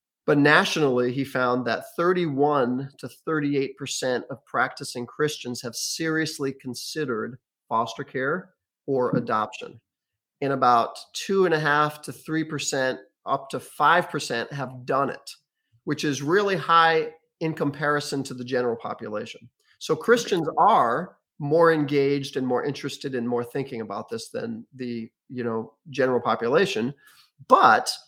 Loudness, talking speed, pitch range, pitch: -24 LUFS, 140 wpm, 125-155 Hz, 140 Hz